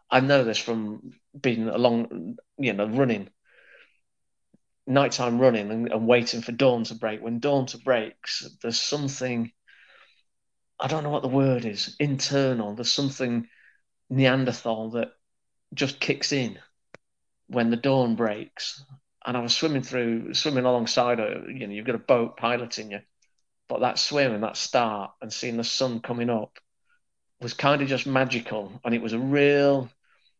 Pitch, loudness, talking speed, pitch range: 120 Hz, -25 LUFS, 160 wpm, 115-135 Hz